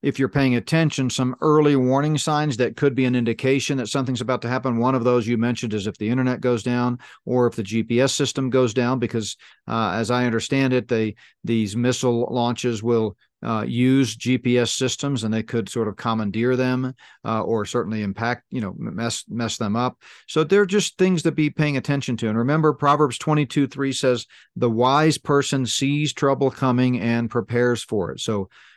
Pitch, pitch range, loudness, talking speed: 125 Hz, 115-140 Hz, -22 LUFS, 195 wpm